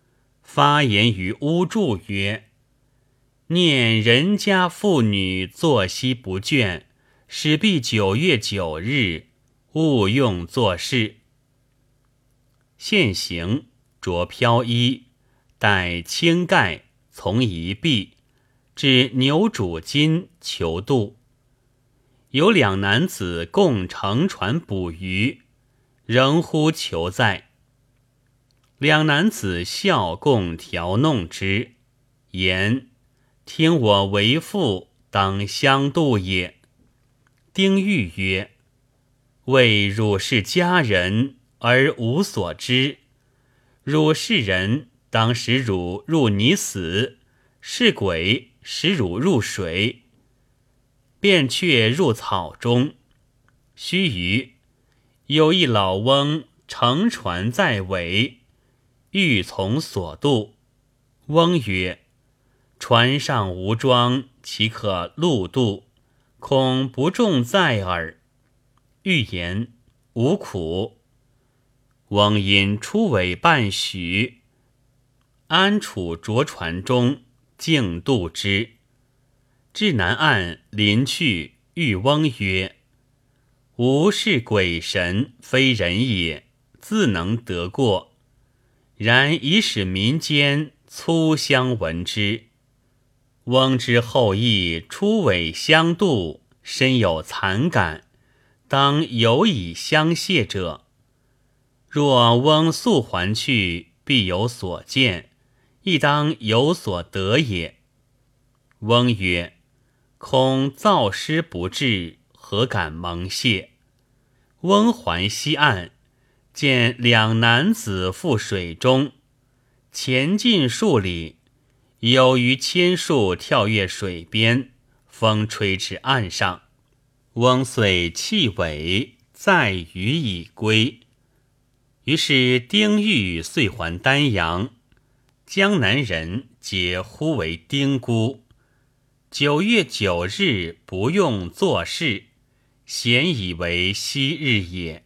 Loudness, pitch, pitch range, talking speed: -20 LUFS, 125 Hz, 105-135 Hz, 120 characters per minute